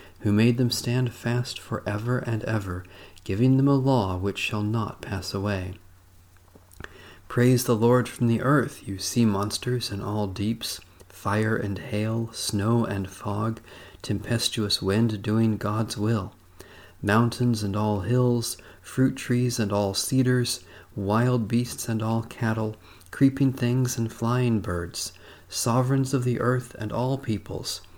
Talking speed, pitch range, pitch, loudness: 145 wpm, 100-120 Hz, 110 Hz, -25 LUFS